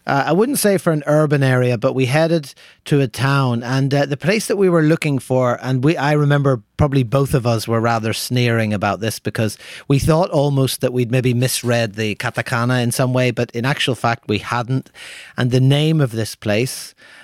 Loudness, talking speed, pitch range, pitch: -17 LUFS, 210 wpm, 120-145 Hz, 130 Hz